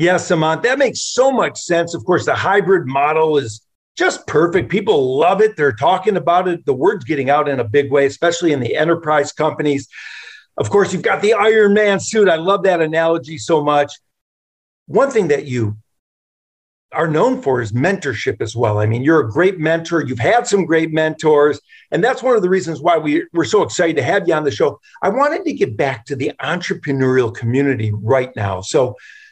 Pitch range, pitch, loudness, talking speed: 140-200 Hz, 160 Hz, -16 LUFS, 205 wpm